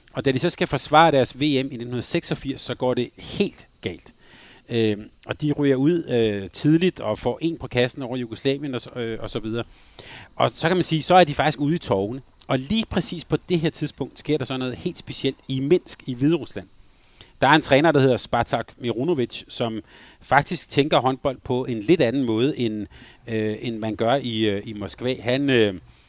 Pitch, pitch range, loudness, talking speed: 130 Hz, 115-145 Hz, -23 LUFS, 205 wpm